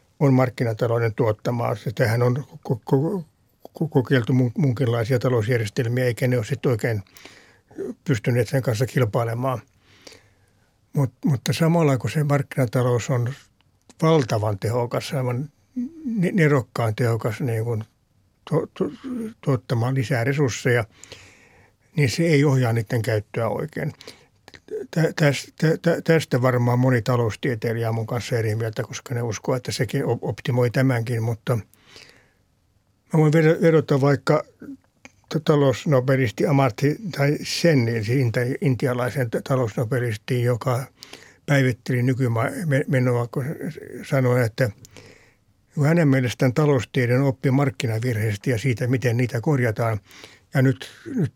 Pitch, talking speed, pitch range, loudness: 130 Hz, 100 wpm, 115-140 Hz, -22 LUFS